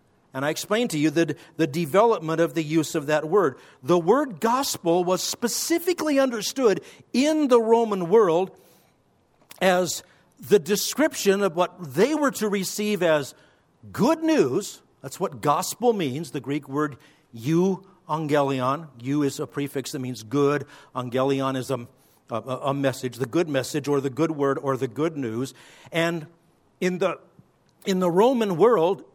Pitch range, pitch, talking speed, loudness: 140-200 Hz, 165 Hz, 155 wpm, -24 LUFS